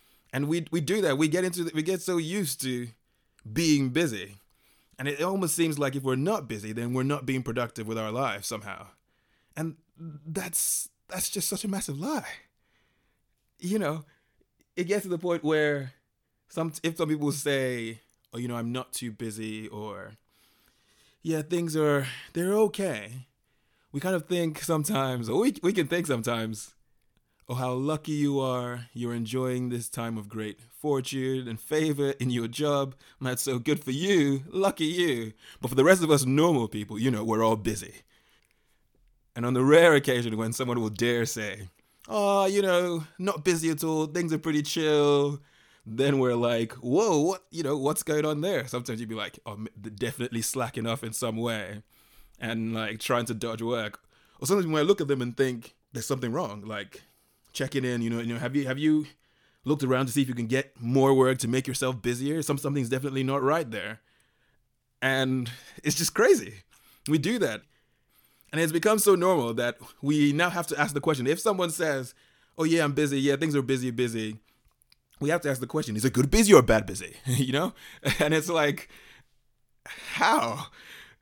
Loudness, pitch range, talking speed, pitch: -27 LUFS, 120-160 Hz, 195 wpm, 135 Hz